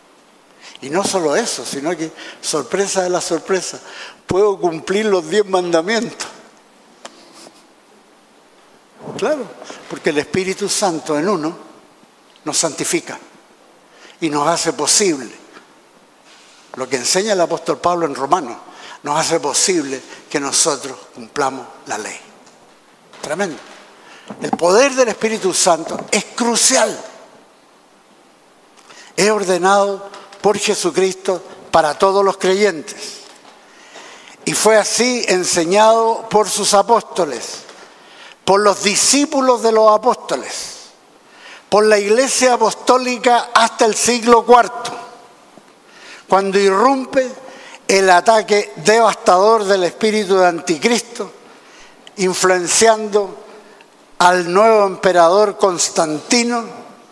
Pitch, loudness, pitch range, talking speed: 205 Hz, -15 LUFS, 185-230 Hz, 100 wpm